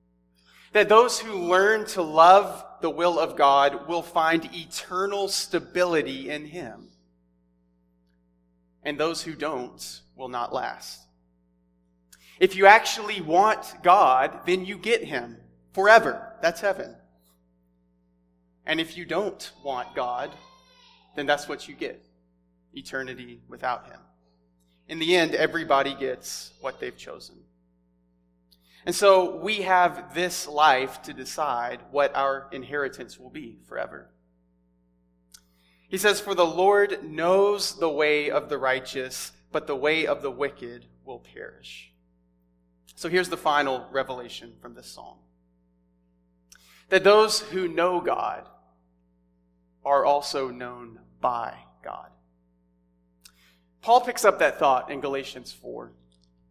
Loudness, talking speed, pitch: -23 LUFS, 125 wpm, 130 Hz